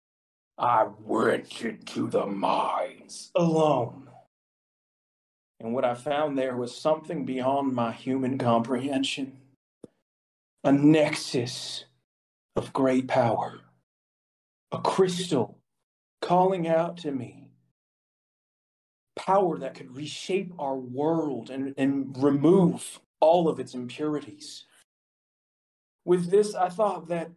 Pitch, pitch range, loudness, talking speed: 140 Hz, 125-160 Hz, -26 LUFS, 100 wpm